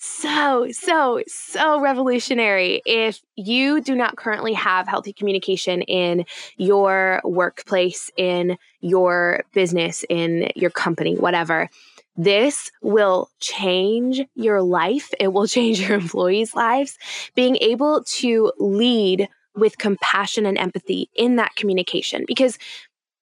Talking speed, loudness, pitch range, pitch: 115 wpm, -20 LUFS, 185-245 Hz, 205 Hz